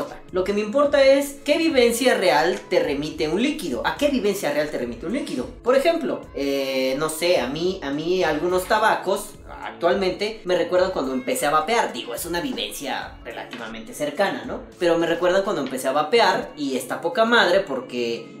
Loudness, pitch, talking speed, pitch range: -22 LUFS, 180 Hz, 185 wpm, 150-235 Hz